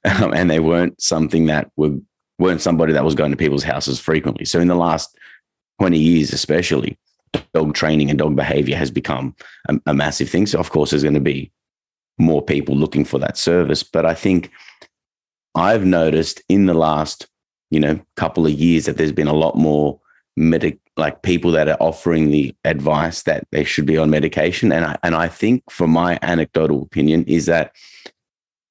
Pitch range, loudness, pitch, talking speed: 75-85 Hz, -17 LUFS, 80 Hz, 190 wpm